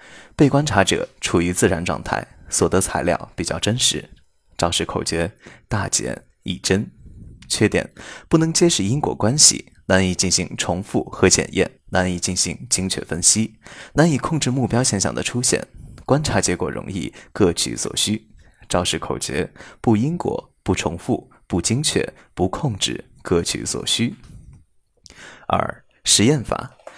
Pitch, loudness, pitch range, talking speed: 95 Hz, -20 LUFS, 85-125 Hz, 220 characters per minute